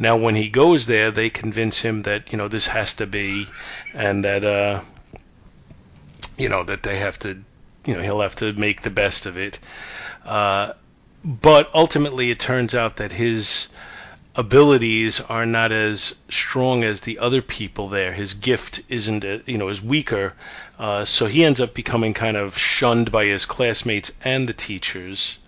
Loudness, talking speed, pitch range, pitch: -20 LUFS, 175 wpm, 105-125 Hz, 110 Hz